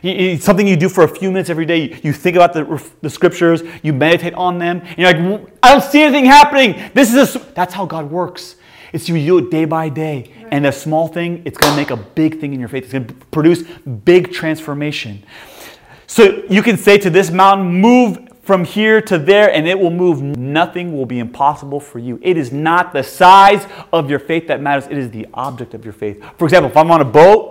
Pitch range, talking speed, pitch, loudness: 145-190 Hz, 235 wpm, 170 Hz, -12 LUFS